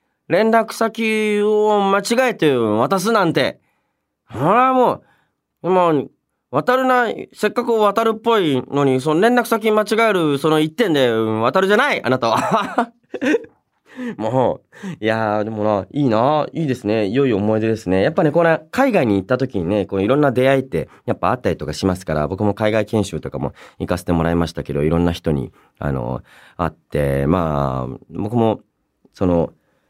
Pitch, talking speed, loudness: 135 Hz, 320 characters per minute, -18 LUFS